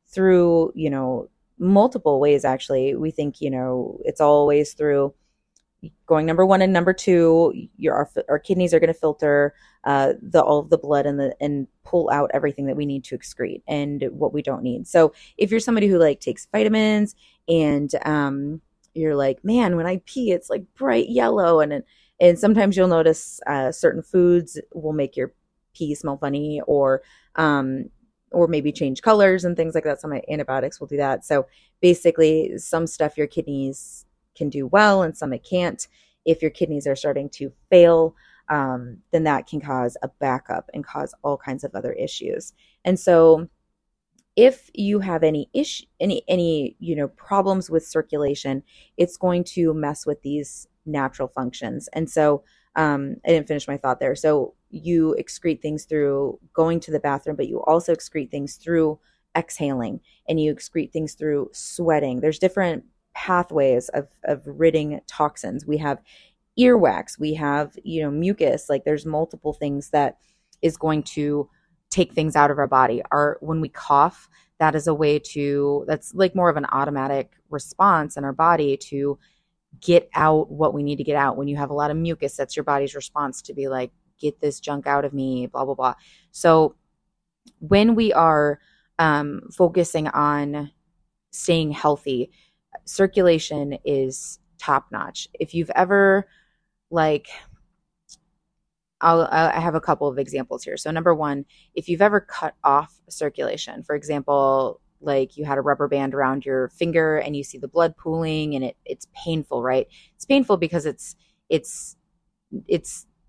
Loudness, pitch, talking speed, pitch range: -21 LUFS, 155 Hz, 175 wpm, 145-175 Hz